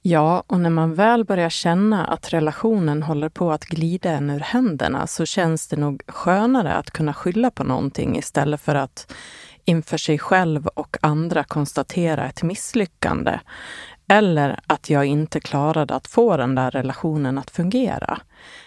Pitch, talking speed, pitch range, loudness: 160 Hz, 155 wpm, 145-180 Hz, -21 LUFS